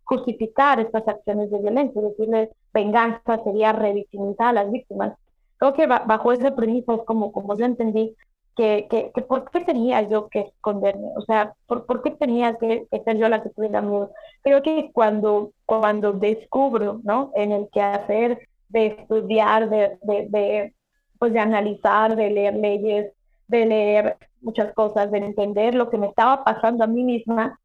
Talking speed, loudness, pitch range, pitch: 170 wpm, -21 LUFS, 210-235 Hz, 220 Hz